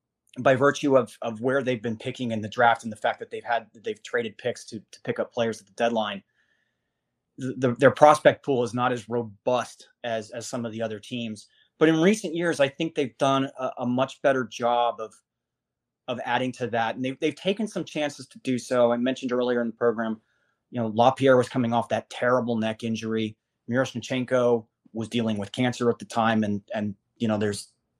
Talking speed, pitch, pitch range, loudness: 215 wpm, 120 Hz, 115-130 Hz, -25 LUFS